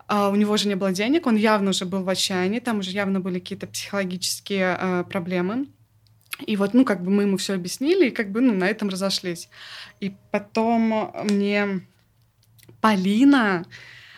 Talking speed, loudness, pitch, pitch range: 175 wpm, -22 LUFS, 195 Hz, 185-215 Hz